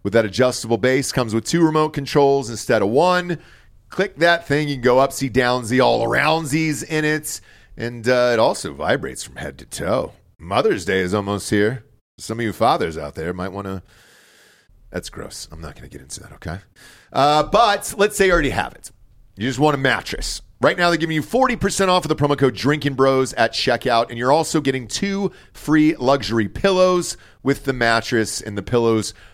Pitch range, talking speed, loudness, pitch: 115-155 Hz, 200 wpm, -19 LUFS, 130 Hz